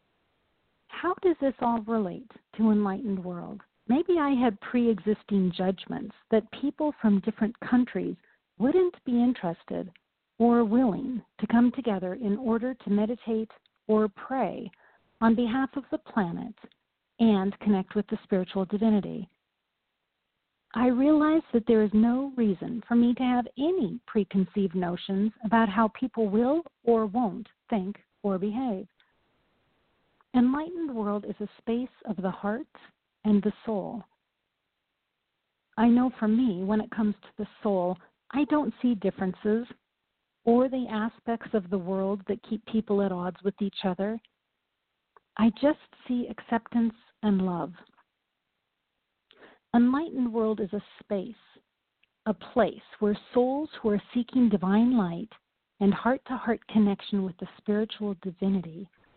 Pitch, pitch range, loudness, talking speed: 225 Hz, 205-245 Hz, -27 LUFS, 135 wpm